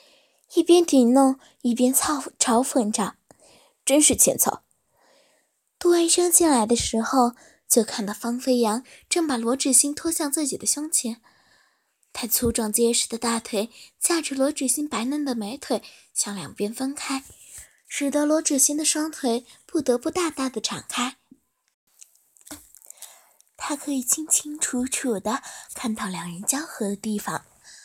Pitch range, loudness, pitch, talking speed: 235-295 Hz, -22 LUFS, 265 Hz, 205 characters per minute